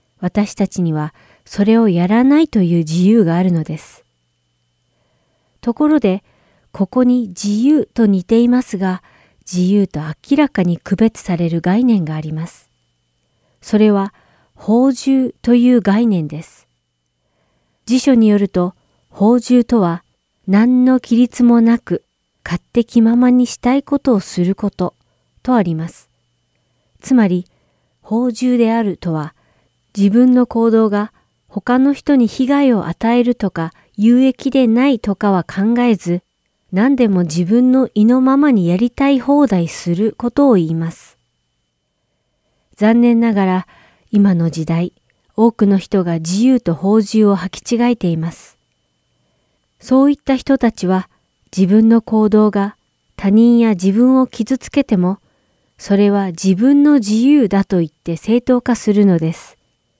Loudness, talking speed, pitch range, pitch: -14 LUFS, 250 characters per minute, 175-245 Hz, 210 Hz